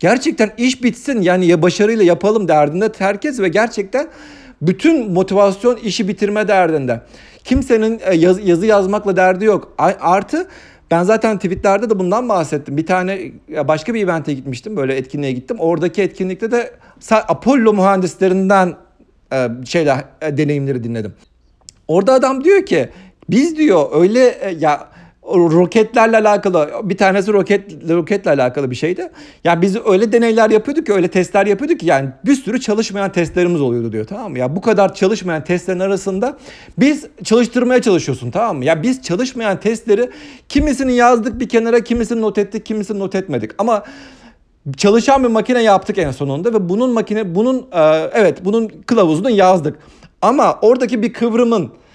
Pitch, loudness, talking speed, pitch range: 200 Hz, -15 LUFS, 150 wpm, 175-235 Hz